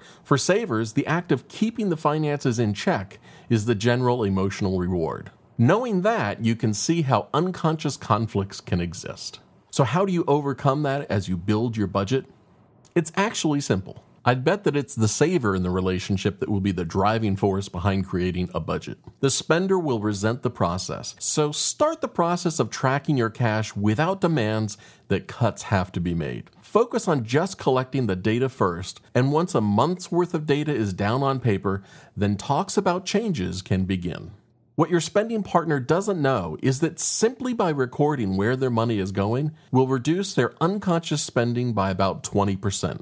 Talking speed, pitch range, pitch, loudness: 180 wpm, 100-160 Hz, 125 Hz, -24 LUFS